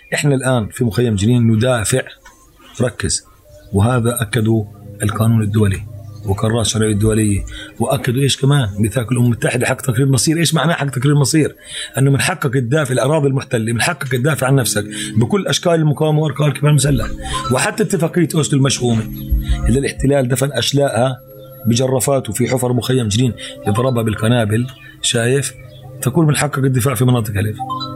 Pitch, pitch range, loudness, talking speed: 130 Hz, 110-140 Hz, -16 LUFS, 145 wpm